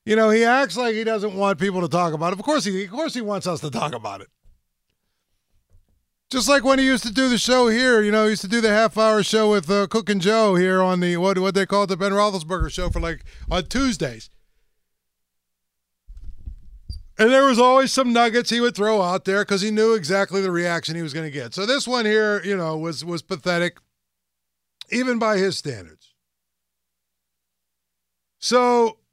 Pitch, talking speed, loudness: 195 Hz, 210 wpm, -20 LUFS